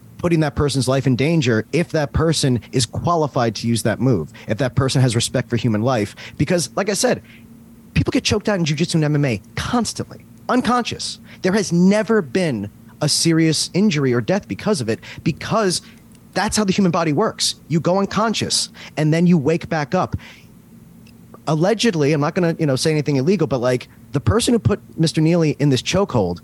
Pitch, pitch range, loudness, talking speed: 150 Hz, 125-180 Hz, -19 LUFS, 195 wpm